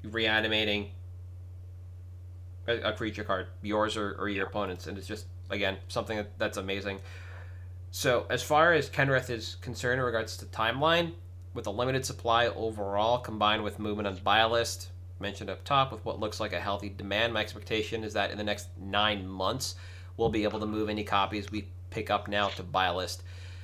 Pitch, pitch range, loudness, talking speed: 100 Hz, 90-110 Hz, -30 LUFS, 190 wpm